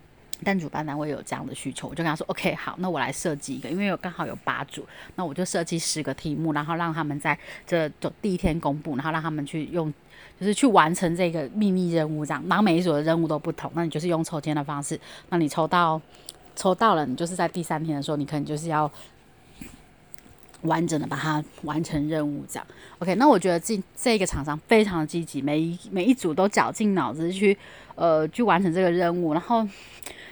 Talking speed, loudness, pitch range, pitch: 330 characters per minute, -25 LUFS, 150-180 Hz, 165 Hz